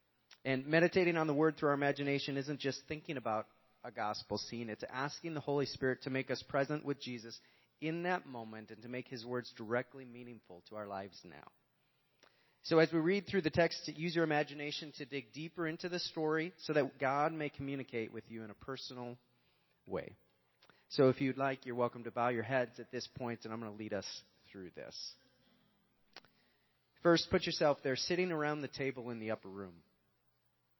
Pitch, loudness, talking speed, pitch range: 135 Hz, -37 LUFS, 195 wpm, 115-155 Hz